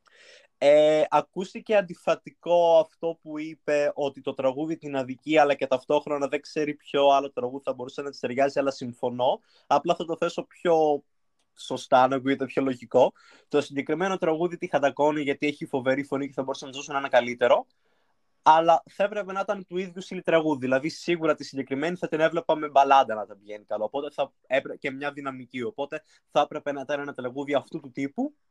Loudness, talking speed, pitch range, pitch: -26 LUFS, 185 wpm, 135-165 Hz, 145 Hz